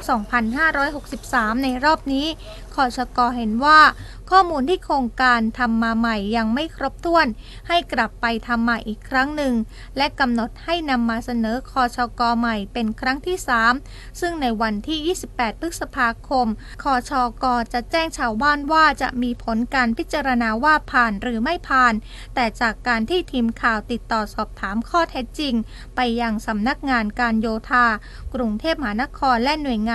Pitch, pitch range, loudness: 250 Hz, 230-285 Hz, -20 LUFS